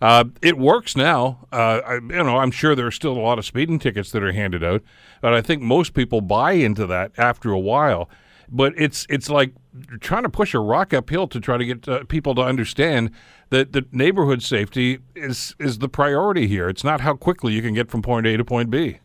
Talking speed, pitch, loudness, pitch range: 235 wpm, 125 Hz, -20 LUFS, 115-140 Hz